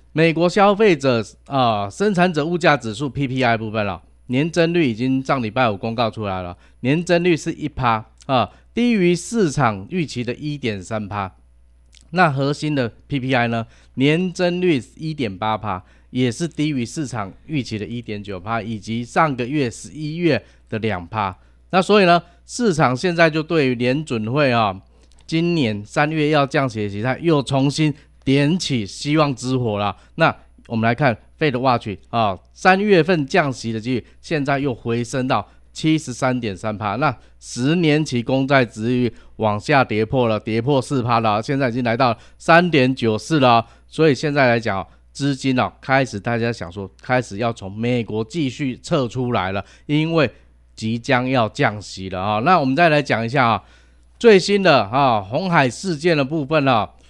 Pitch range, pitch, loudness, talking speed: 110-150 Hz, 130 Hz, -19 LUFS, 255 characters per minute